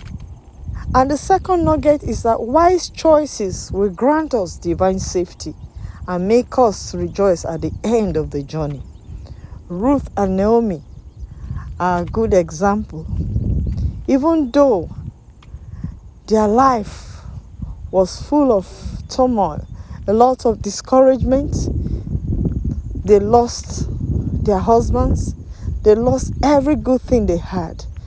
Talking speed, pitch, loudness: 115 wpm, 200 Hz, -17 LUFS